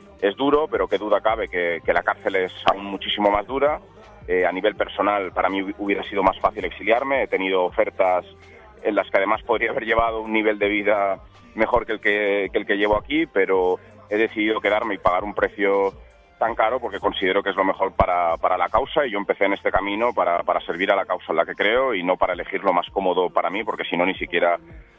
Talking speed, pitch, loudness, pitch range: 240 wpm, 105 Hz, -22 LUFS, 95-110 Hz